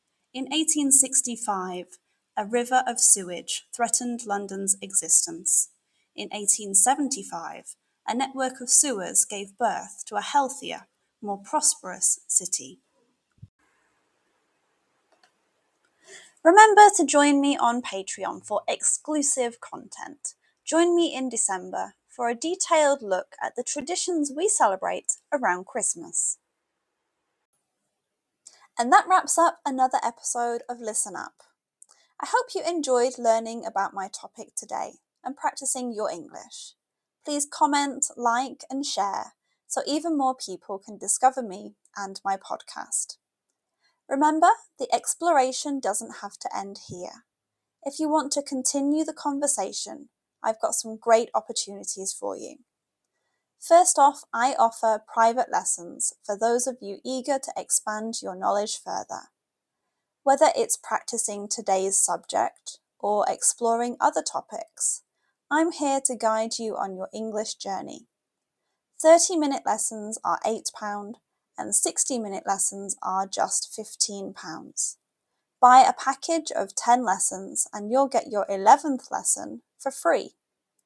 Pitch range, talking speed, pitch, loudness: 210-290 Hz, 125 wpm, 250 Hz, -24 LUFS